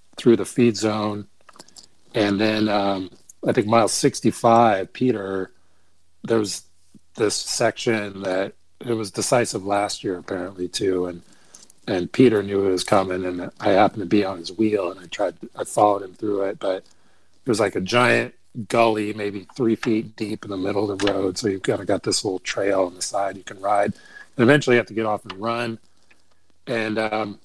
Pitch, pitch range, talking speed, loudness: 100 Hz, 95-110 Hz, 195 wpm, -22 LUFS